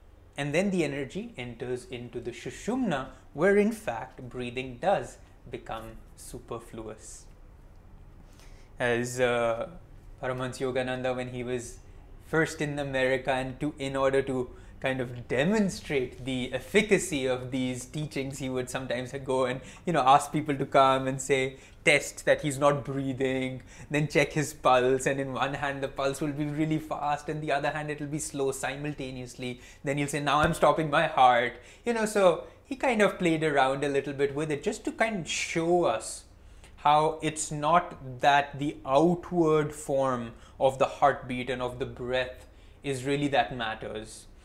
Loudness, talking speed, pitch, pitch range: -28 LUFS, 165 wpm, 135 Hz, 125-150 Hz